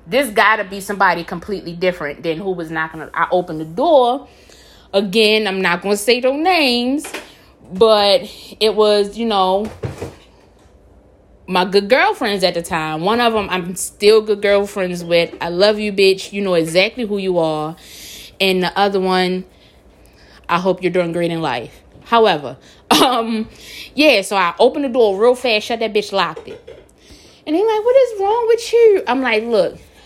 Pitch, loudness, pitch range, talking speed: 205 Hz, -16 LUFS, 180-240 Hz, 175 wpm